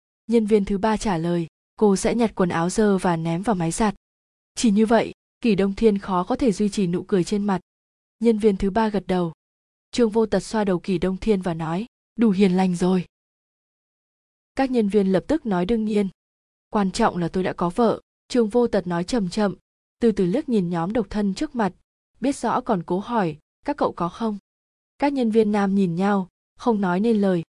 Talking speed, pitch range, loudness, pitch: 220 wpm, 185-225 Hz, -22 LUFS, 205 Hz